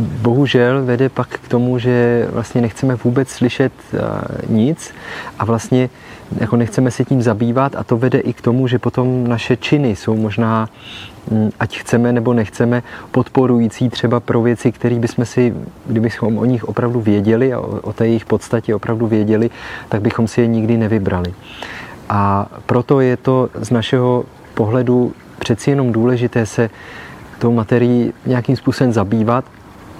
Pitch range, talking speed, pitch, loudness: 115-125 Hz, 150 wpm, 120 Hz, -16 LUFS